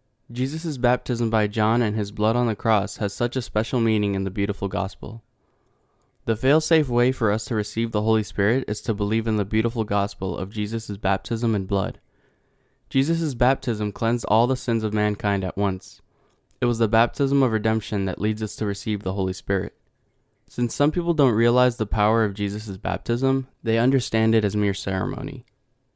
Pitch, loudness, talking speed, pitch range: 110 Hz, -23 LUFS, 185 wpm, 105-125 Hz